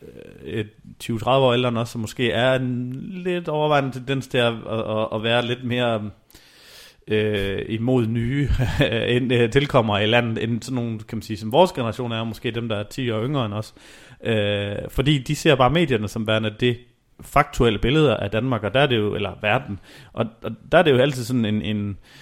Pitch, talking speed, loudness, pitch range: 120 Hz, 195 wpm, -22 LUFS, 110-130 Hz